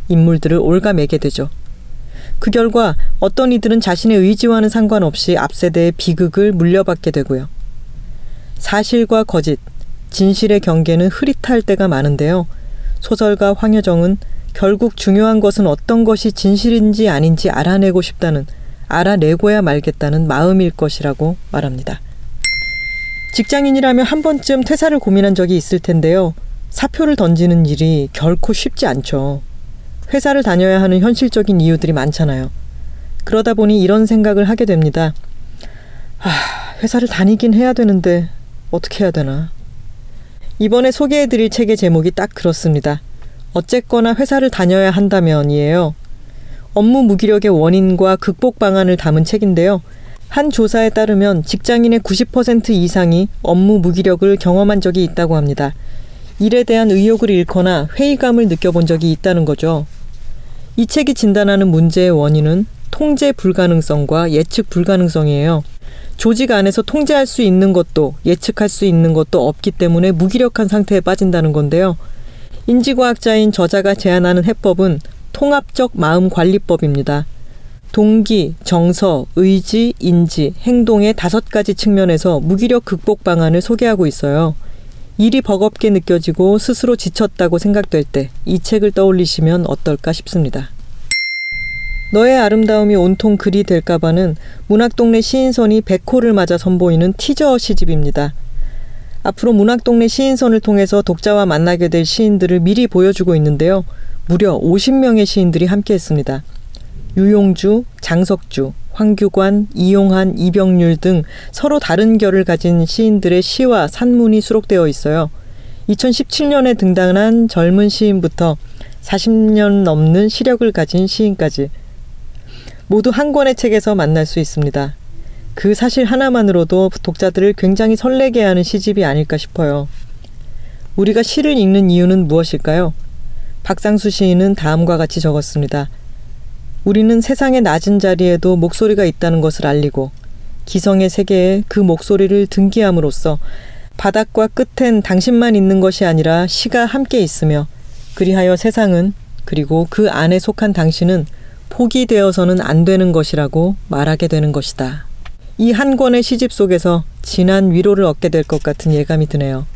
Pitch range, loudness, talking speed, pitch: 160-220 Hz, -13 LUFS, 315 characters per minute, 190 Hz